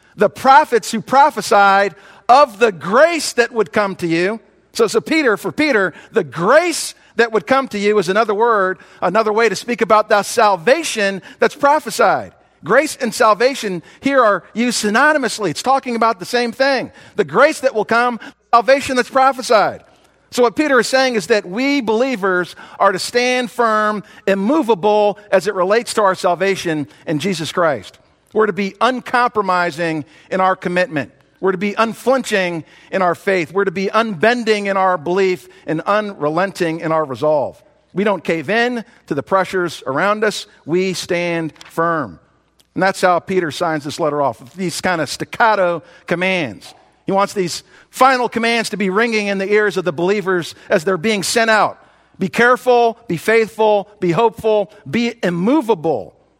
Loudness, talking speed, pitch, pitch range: -16 LUFS, 170 wpm, 210 Hz, 185-235 Hz